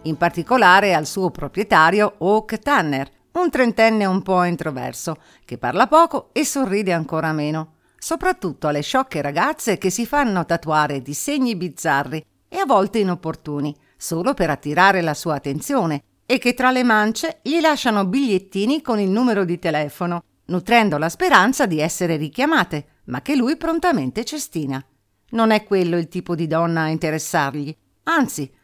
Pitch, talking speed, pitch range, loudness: 185 Hz, 155 wpm, 155-245 Hz, -19 LUFS